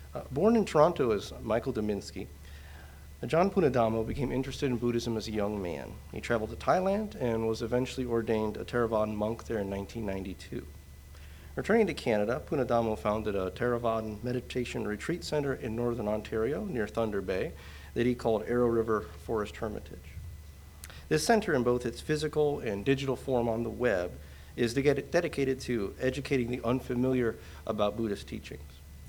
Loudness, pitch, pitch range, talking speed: -31 LUFS, 115 Hz, 100-130 Hz, 155 wpm